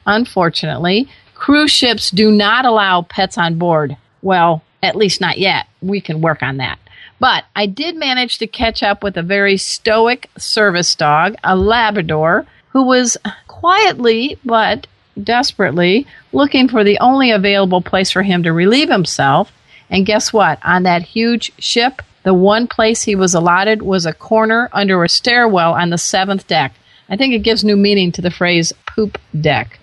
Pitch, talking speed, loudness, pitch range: 200 Hz, 170 wpm, -13 LUFS, 175-230 Hz